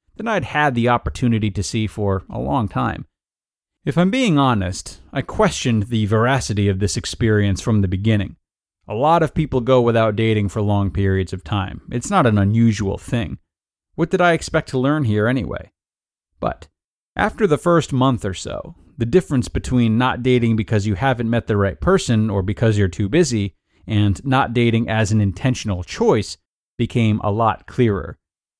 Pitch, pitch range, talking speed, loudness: 110 Hz, 100-130 Hz, 180 wpm, -19 LUFS